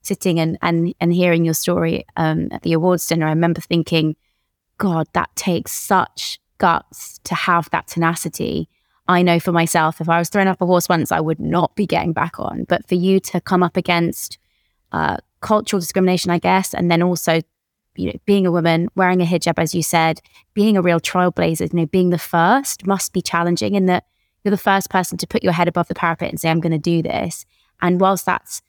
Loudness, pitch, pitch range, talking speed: -18 LUFS, 175 Hz, 165-185 Hz, 220 wpm